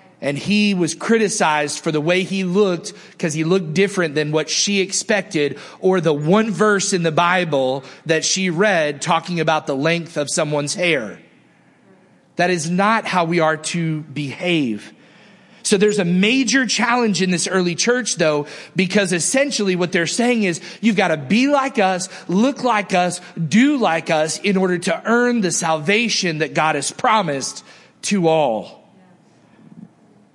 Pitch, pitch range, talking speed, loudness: 180 Hz, 160-205 Hz, 160 wpm, -18 LUFS